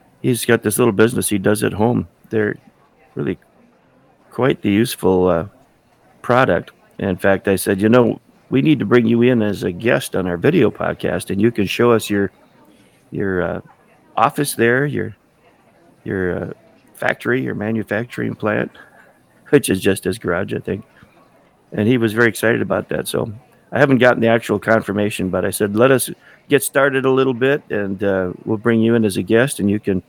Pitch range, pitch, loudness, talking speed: 100-125 Hz, 110 Hz, -17 LUFS, 190 wpm